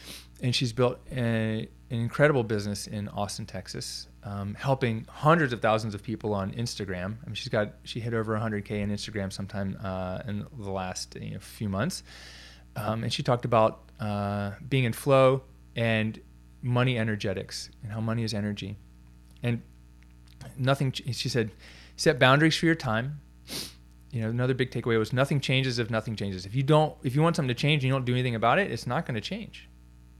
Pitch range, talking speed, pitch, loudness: 95-125 Hz, 195 wpm, 110 Hz, -28 LUFS